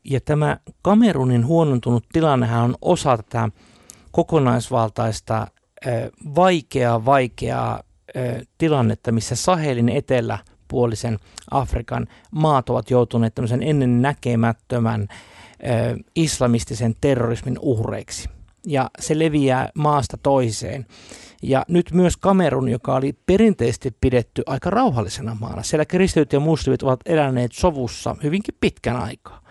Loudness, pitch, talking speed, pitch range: -20 LUFS, 125 Hz, 105 wpm, 115-150 Hz